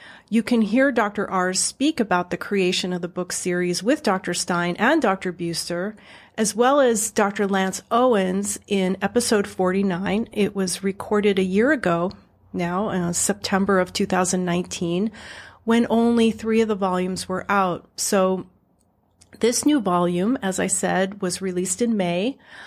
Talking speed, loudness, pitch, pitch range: 155 wpm, -22 LUFS, 195 Hz, 180-220 Hz